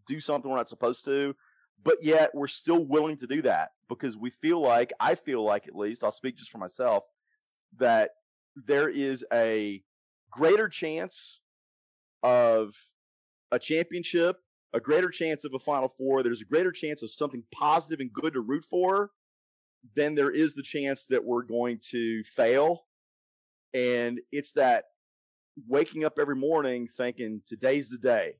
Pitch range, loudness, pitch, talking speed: 120-155 Hz, -28 LUFS, 135 Hz, 165 wpm